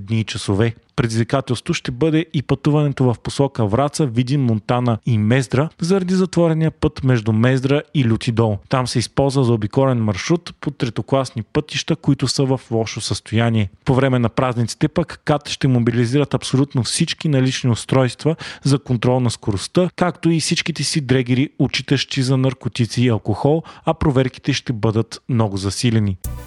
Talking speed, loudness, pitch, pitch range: 155 wpm, -19 LUFS, 130 Hz, 115-145 Hz